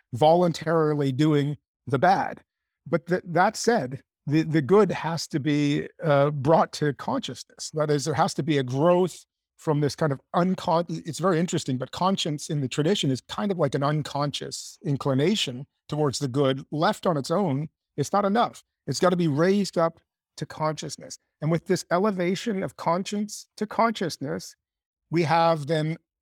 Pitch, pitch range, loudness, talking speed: 160 Hz, 145-180 Hz, -25 LUFS, 170 wpm